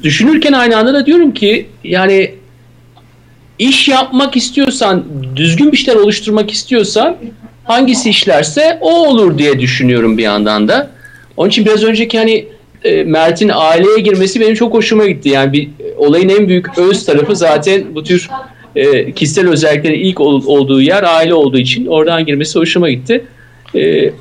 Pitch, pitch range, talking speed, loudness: 195 Hz, 150-235 Hz, 145 wpm, -10 LUFS